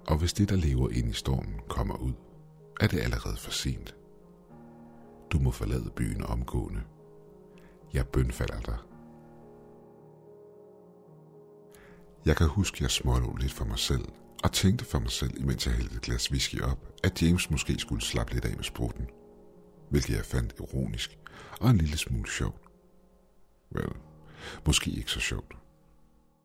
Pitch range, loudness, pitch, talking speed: 60-85 Hz, -30 LUFS, 75 Hz, 155 wpm